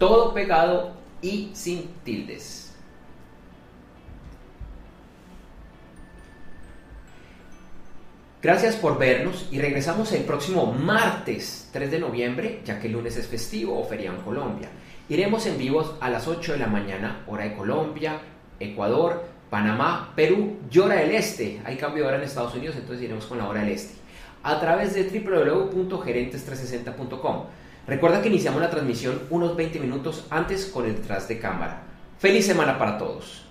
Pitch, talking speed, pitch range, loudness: 140 Hz, 145 wpm, 115-170 Hz, -25 LUFS